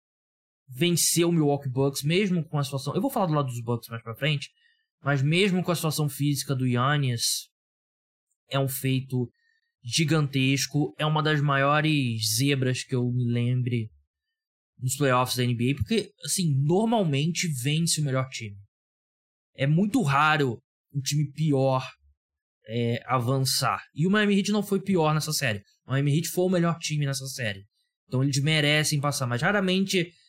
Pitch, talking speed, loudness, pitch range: 145 Hz, 160 wpm, -25 LUFS, 130-165 Hz